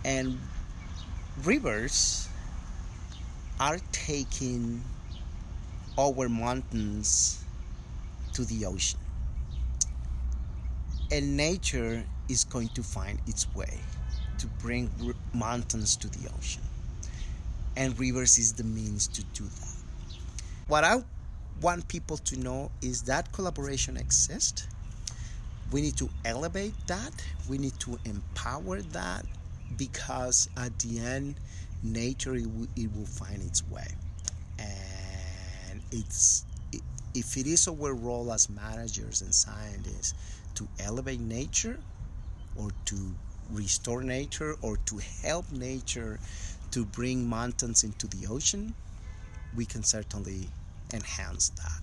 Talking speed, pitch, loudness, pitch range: 110 wpm, 100 Hz, -31 LUFS, 85-120 Hz